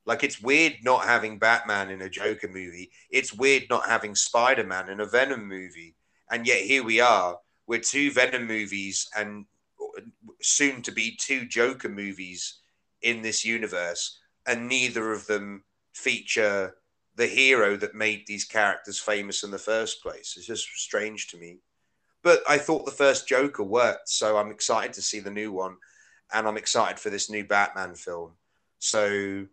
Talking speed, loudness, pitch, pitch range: 170 wpm, -25 LUFS, 105 Hz, 100-120 Hz